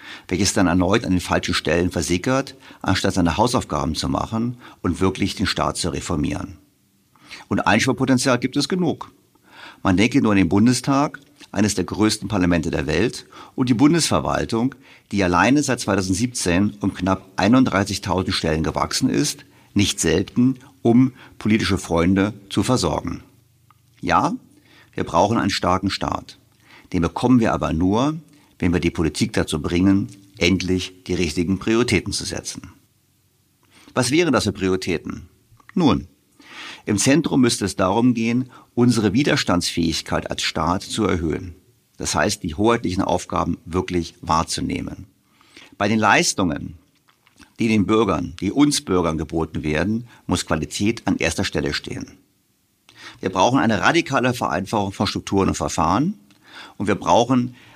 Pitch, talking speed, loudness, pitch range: 95 Hz, 140 wpm, -20 LUFS, 90-120 Hz